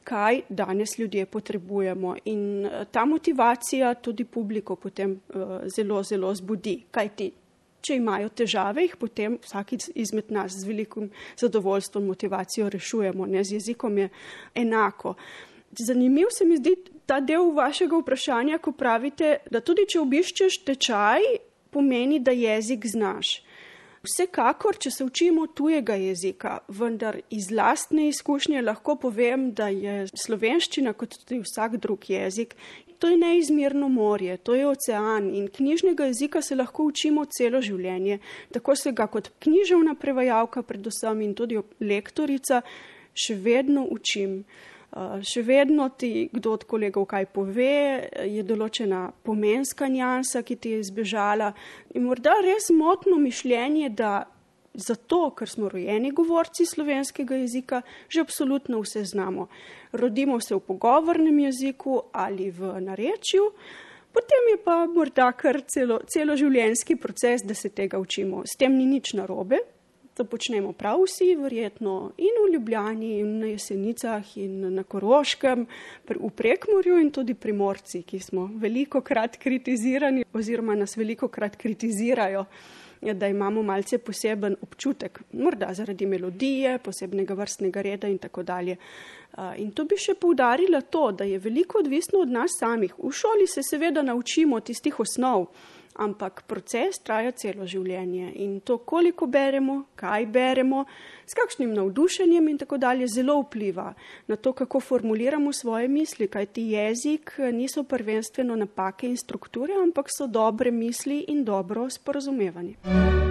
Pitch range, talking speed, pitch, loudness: 205-280 Hz, 140 wpm, 240 Hz, -25 LUFS